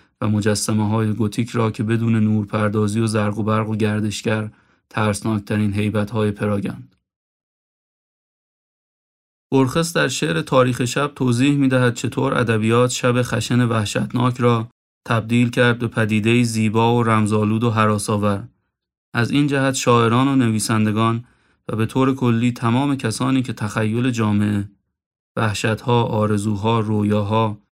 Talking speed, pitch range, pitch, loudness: 130 wpm, 105-125 Hz, 115 Hz, -19 LUFS